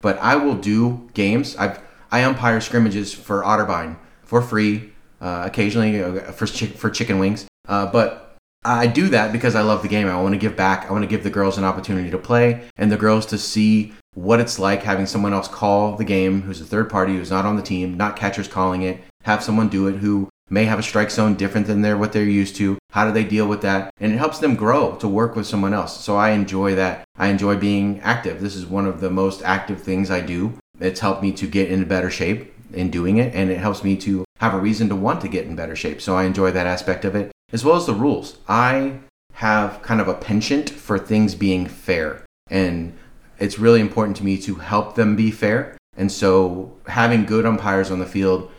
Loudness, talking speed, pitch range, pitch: -20 LUFS, 235 wpm, 95-110 Hz, 100 Hz